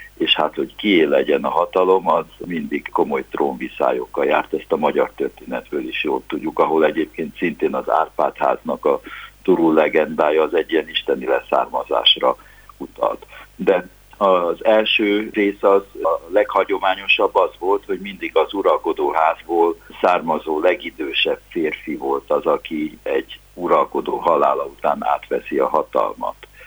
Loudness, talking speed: -19 LUFS, 130 wpm